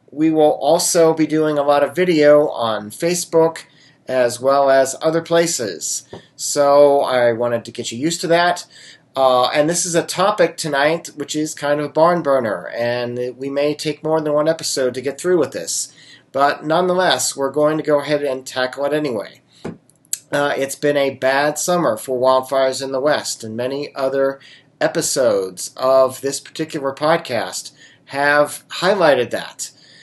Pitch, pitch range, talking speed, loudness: 145 Hz, 130-160 Hz, 170 wpm, -17 LUFS